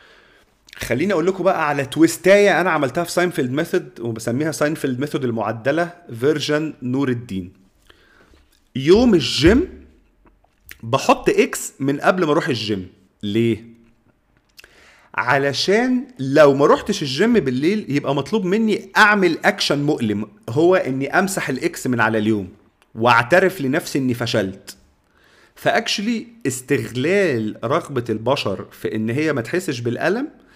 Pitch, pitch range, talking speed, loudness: 140 Hz, 115-175 Hz, 120 wpm, -19 LUFS